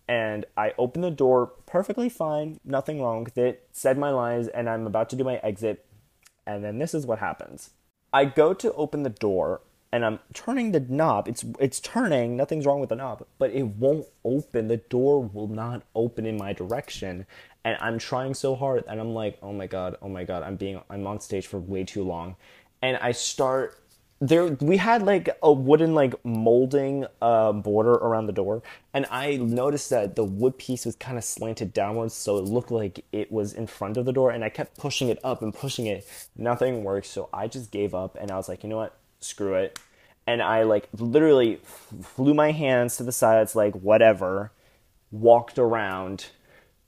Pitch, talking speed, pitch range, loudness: 115 Hz, 205 wpm, 105-135 Hz, -25 LUFS